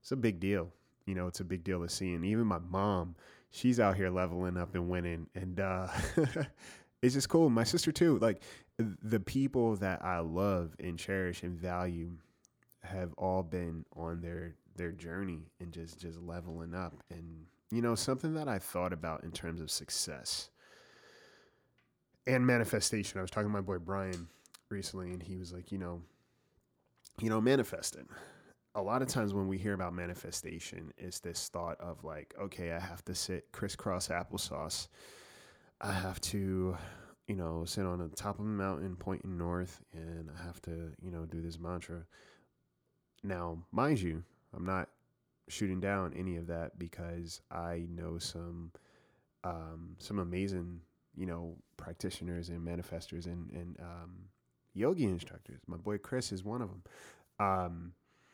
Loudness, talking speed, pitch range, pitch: -37 LUFS, 170 wpm, 85-100 Hz, 90 Hz